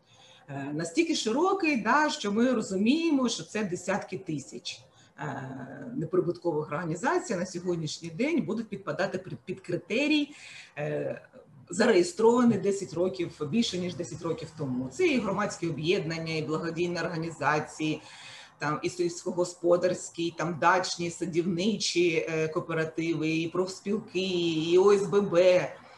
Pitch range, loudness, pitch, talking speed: 160-200 Hz, -28 LUFS, 175 Hz, 110 wpm